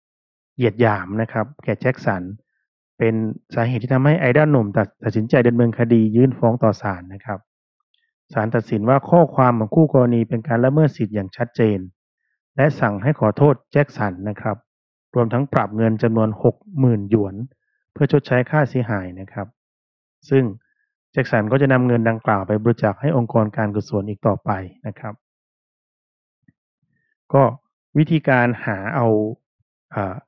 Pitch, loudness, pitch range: 115 Hz, -19 LUFS, 105-135 Hz